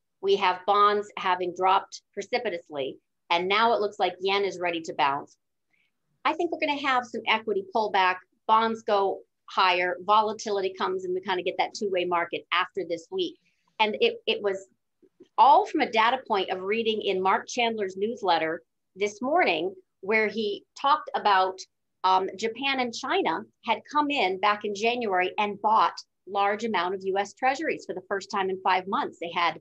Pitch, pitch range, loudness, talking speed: 205 Hz, 185-230 Hz, -26 LUFS, 180 wpm